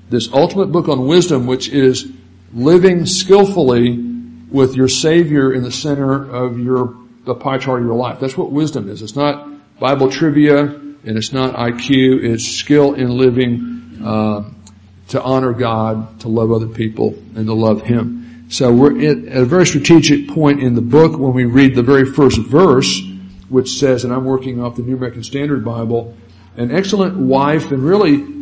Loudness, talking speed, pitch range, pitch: -14 LUFS, 175 wpm, 120-145 Hz, 130 Hz